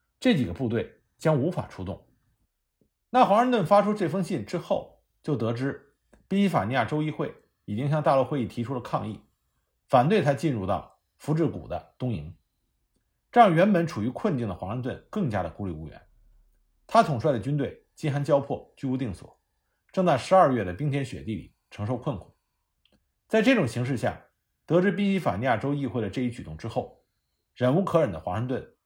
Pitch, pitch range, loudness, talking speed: 140 Hz, 115-180 Hz, -26 LUFS, 280 characters per minute